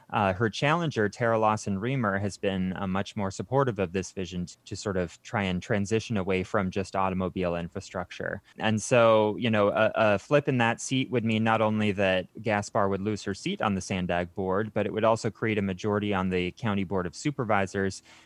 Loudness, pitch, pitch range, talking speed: -27 LUFS, 100 Hz, 95-110 Hz, 210 wpm